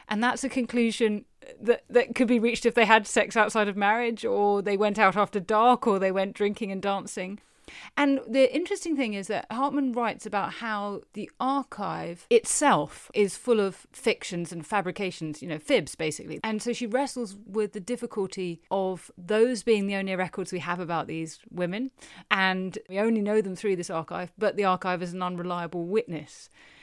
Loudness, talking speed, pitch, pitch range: -27 LUFS, 190 wpm, 205 Hz, 185-235 Hz